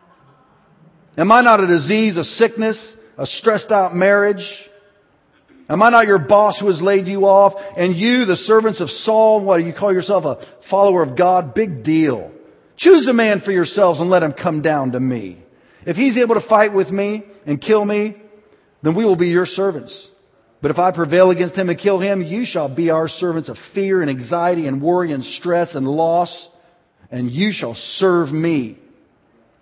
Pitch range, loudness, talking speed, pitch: 170-205 Hz, -16 LUFS, 190 wpm, 185 Hz